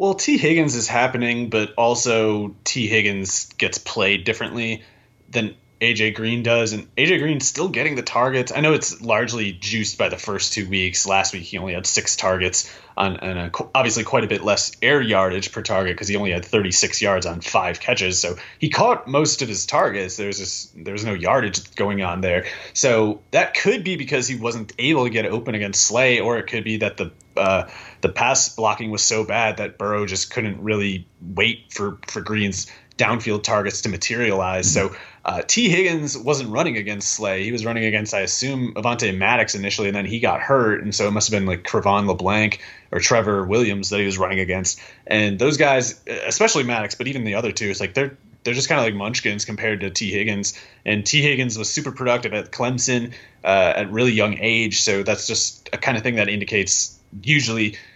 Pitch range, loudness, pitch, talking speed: 100-120 Hz, -20 LUFS, 110 Hz, 205 wpm